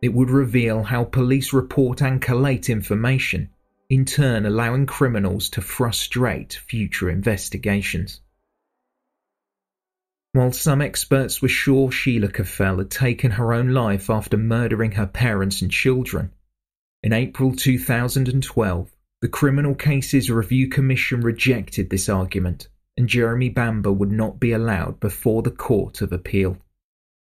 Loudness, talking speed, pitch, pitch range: -21 LUFS, 125 wpm, 115 Hz, 100-130 Hz